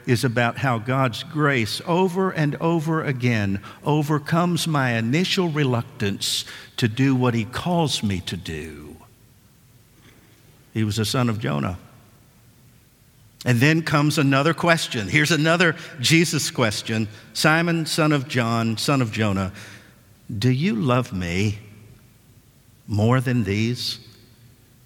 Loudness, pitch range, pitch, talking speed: -21 LUFS, 115-150 Hz, 125 Hz, 120 wpm